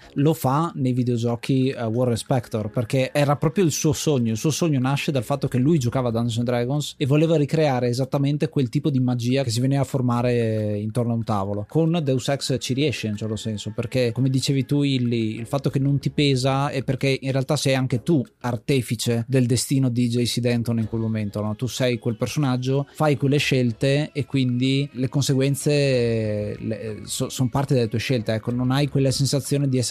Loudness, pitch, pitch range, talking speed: -22 LUFS, 130 Hz, 120-140 Hz, 210 wpm